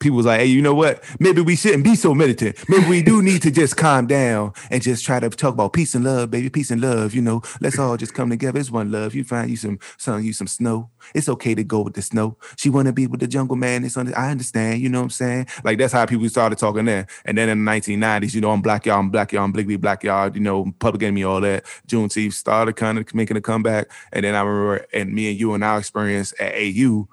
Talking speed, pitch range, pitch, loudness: 280 wpm, 105-130 Hz, 115 Hz, -19 LUFS